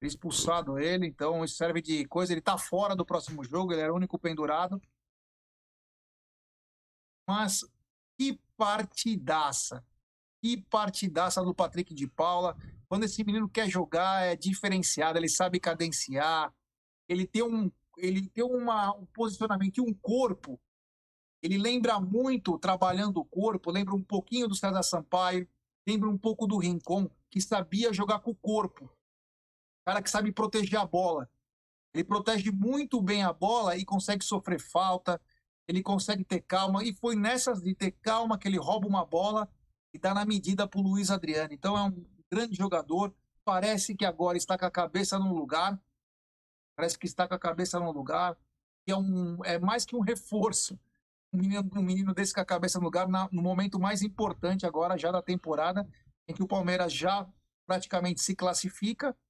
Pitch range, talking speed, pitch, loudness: 175-205 Hz, 170 wpm, 190 Hz, -31 LUFS